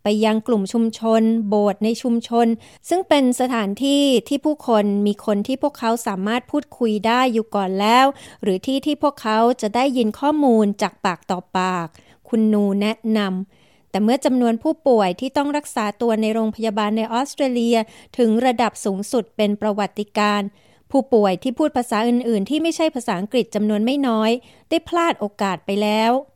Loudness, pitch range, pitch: -20 LUFS, 210-255 Hz, 225 Hz